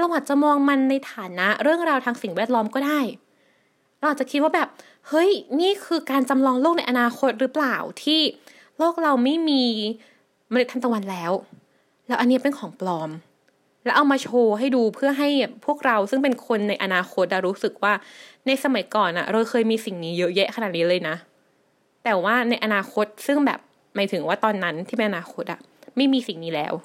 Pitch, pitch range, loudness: 245 Hz, 205-280 Hz, -22 LUFS